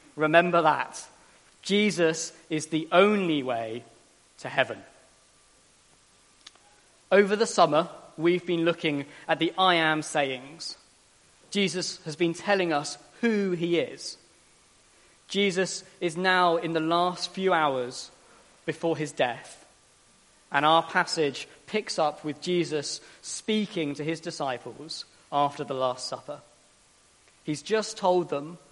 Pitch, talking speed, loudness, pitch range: 165 Hz, 120 wpm, -27 LUFS, 150-180 Hz